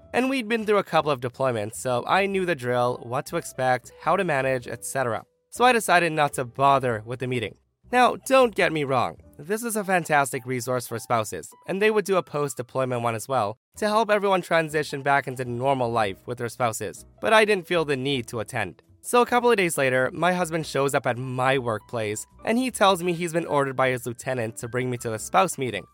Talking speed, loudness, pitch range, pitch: 230 wpm, -24 LUFS, 125-185 Hz, 140 Hz